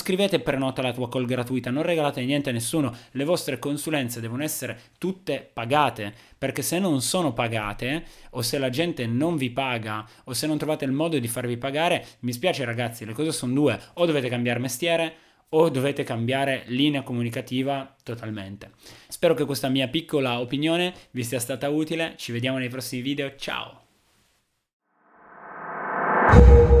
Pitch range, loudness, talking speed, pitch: 125-155 Hz, -25 LUFS, 165 wpm, 135 Hz